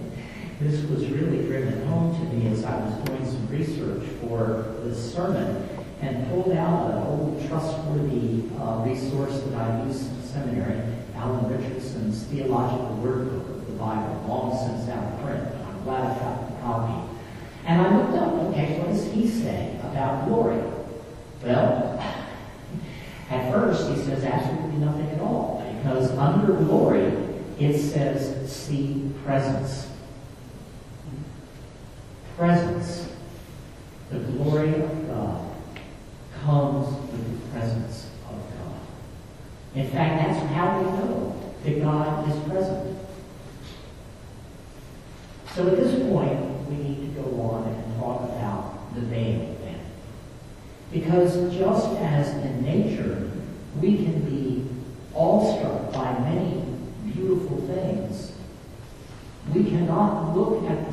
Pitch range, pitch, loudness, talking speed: 120-155 Hz, 135 Hz, -26 LUFS, 125 wpm